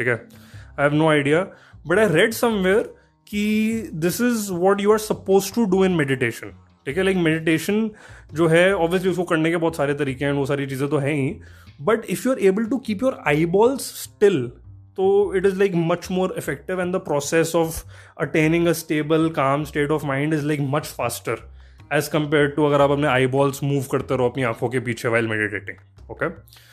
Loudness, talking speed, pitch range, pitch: -21 LUFS, 200 wpm, 135-190 Hz, 155 Hz